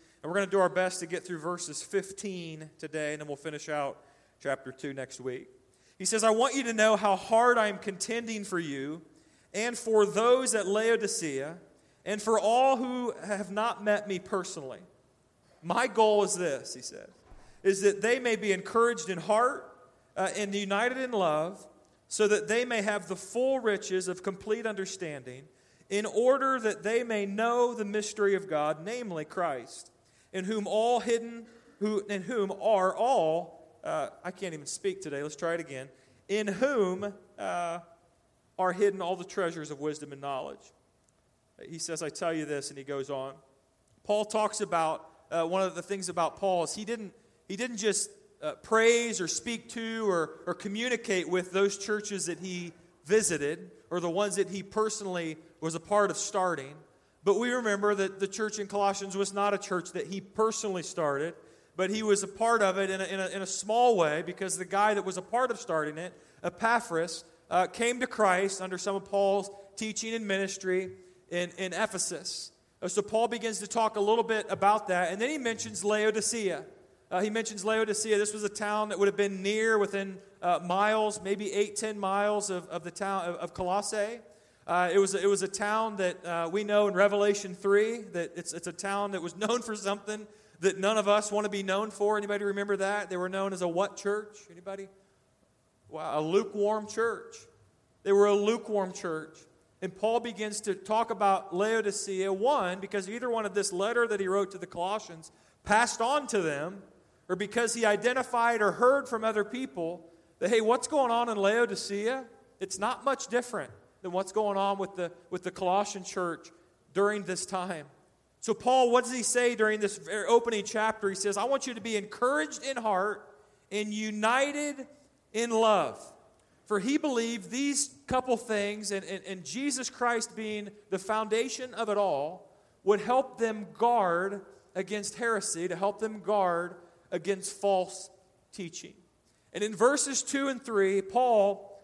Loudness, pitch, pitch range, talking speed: -30 LUFS, 200 Hz, 180-220 Hz, 190 wpm